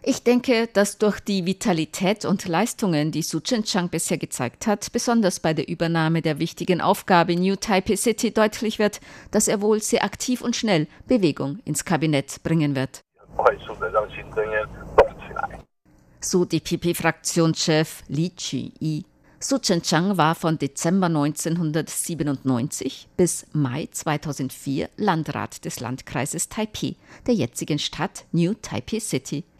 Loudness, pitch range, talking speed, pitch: -23 LUFS, 155-200 Hz, 135 wpm, 170 Hz